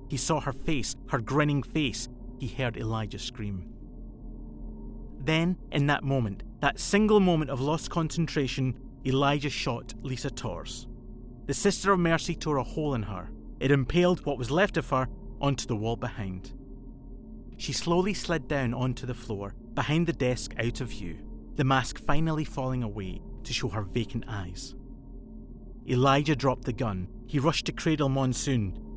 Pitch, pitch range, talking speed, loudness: 130 Hz, 115-150 Hz, 160 wpm, -29 LUFS